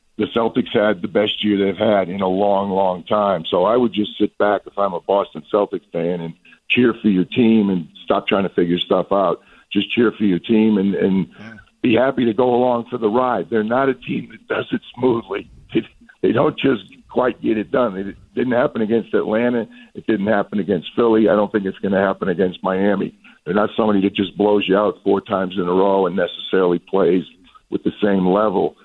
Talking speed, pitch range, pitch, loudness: 225 wpm, 95-115 Hz, 105 Hz, -18 LUFS